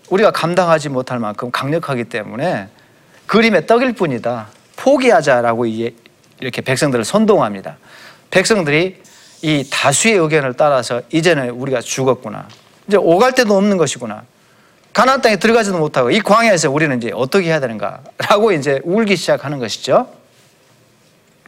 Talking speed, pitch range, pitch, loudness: 345 characters per minute, 125-200 Hz, 160 Hz, -15 LUFS